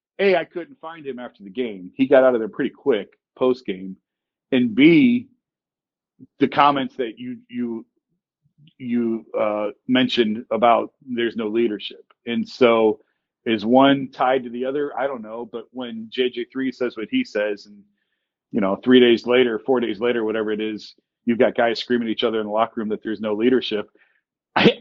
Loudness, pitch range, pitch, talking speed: -20 LUFS, 110-140 Hz, 120 Hz, 185 wpm